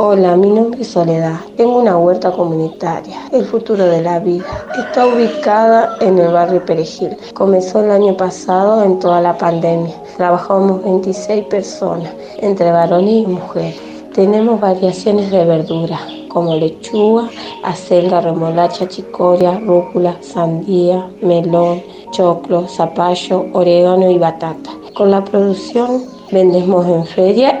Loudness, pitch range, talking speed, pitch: -13 LUFS, 175-205 Hz, 125 wpm, 185 Hz